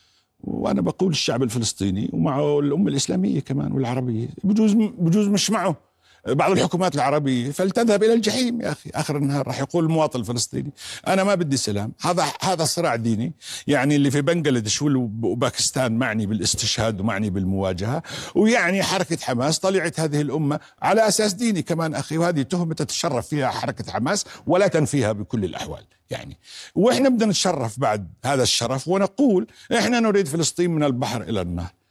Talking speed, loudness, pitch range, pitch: 150 wpm, -22 LUFS, 120-185 Hz, 145 Hz